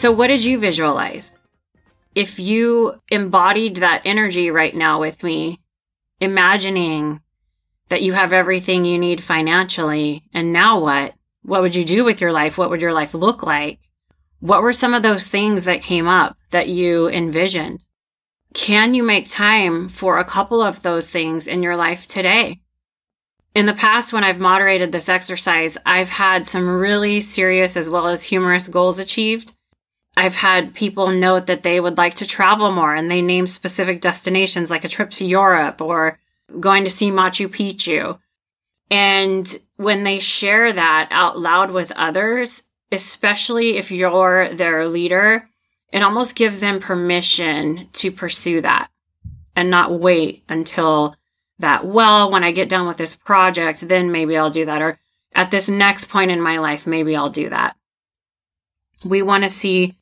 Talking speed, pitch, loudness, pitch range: 165 wpm, 185 Hz, -16 LUFS, 165-200 Hz